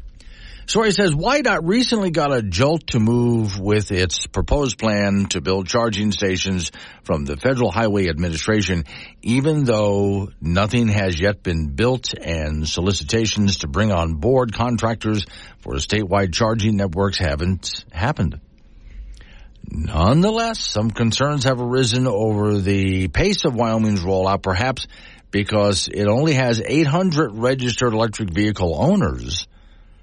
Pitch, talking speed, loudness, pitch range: 105 Hz, 130 wpm, -19 LUFS, 95-120 Hz